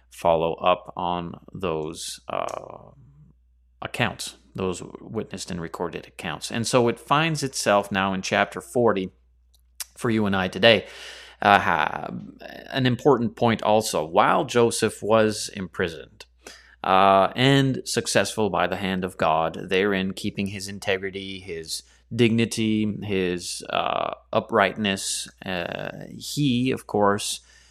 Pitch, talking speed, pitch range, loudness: 100 Hz, 120 wpm, 90-115 Hz, -23 LUFS